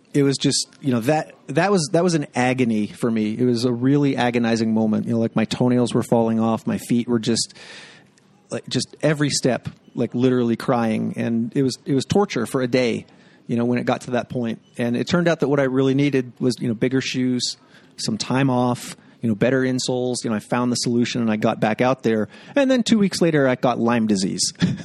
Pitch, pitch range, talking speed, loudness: 125 Hz, 120-135 Hz, 235 wpm, -21 LUFS